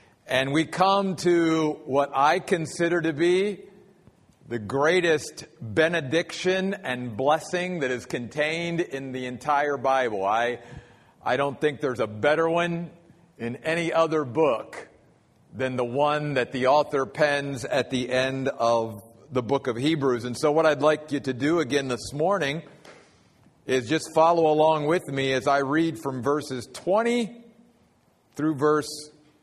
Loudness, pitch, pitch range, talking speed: -25 LUFS, 150 Hz, 130-165 Hz, 150 wpm